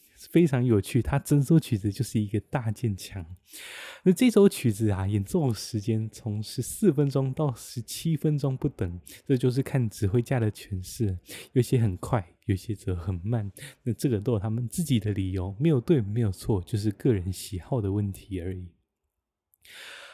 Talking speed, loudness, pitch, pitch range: 255 characters per minute, -27 LUFS, 110 Hz, 100-135 Hz